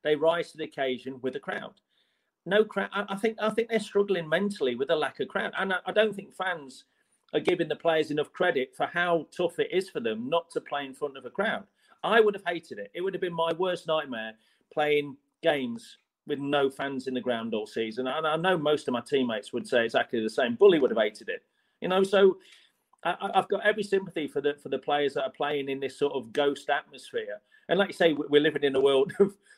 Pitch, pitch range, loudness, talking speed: 165 Hz, 145-200 Hz, -28 LUFS, 255 wpm